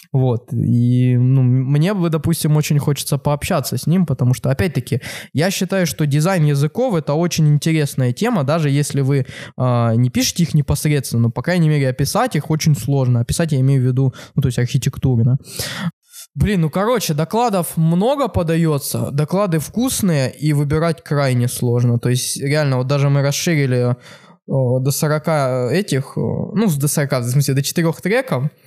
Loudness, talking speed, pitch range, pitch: -17 LUFS, 165 wpm, 130-165 Hz, 145 Hz